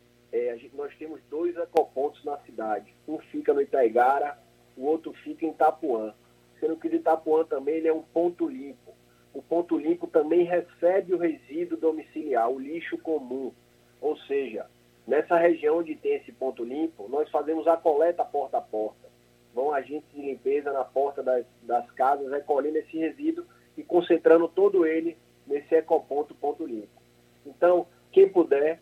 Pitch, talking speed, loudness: 160 Hz, 160 wpm, -26 LUFS